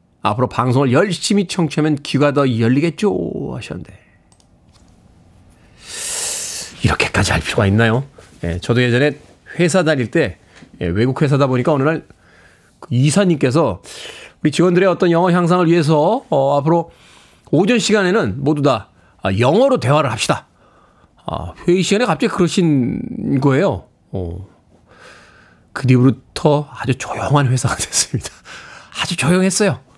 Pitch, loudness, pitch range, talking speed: 145 Hz, -16 LUFS, 120-175 Hz, 285 characters per minute